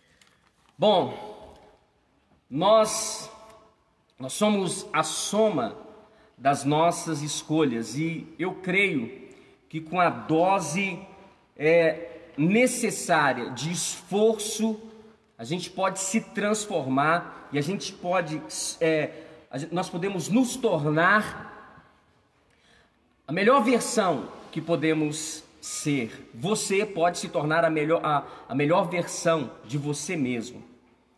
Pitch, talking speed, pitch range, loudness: 175 Hz, 105 wpm, 155-210 Hz, -25 LUFS